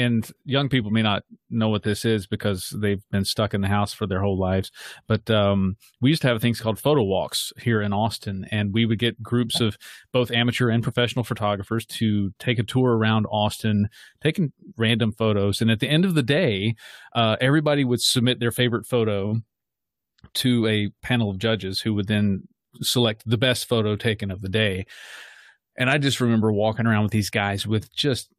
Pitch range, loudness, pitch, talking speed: 105-120 Hz, -23 LUFS, 110 Hz, 200 wpm